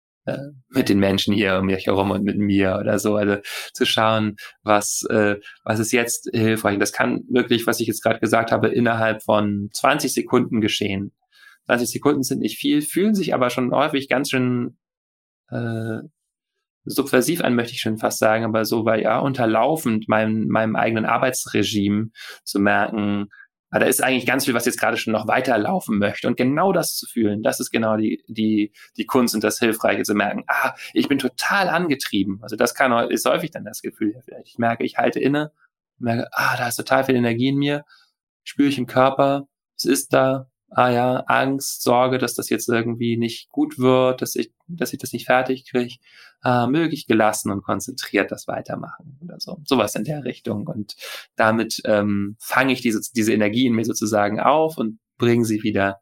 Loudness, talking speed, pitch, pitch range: -21 LUFS, 190 wpm, 115 Hz, 105-130 Hz